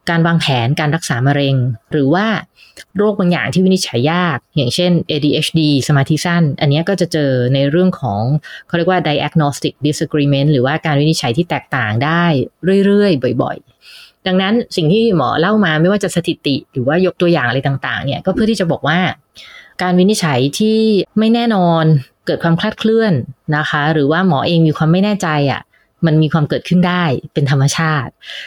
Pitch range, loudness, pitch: 145-180 Hz, -14 LUFS, 160 Hz